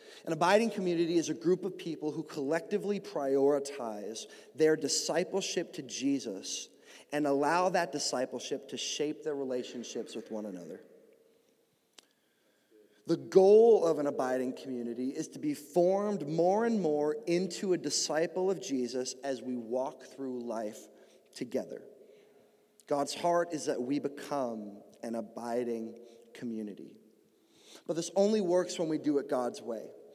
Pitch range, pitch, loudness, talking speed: 130-180 Hz, 150 Hz, -32 LUFS, 135 wpm